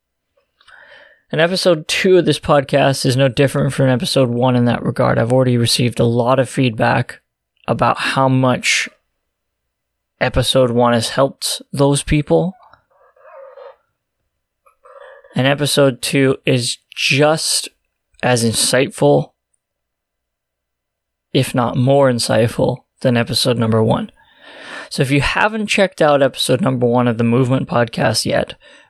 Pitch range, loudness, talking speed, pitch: 120-150 Hz, -15 LUFS, 125 wpm, 135 Hz